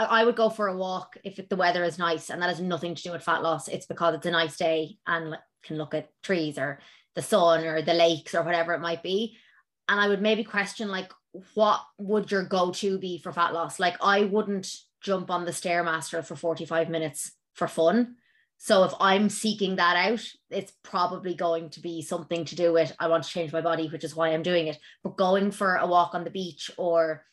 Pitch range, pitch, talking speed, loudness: 165-195 Hz, 175 Hz, 230 wpm, -26 LUFS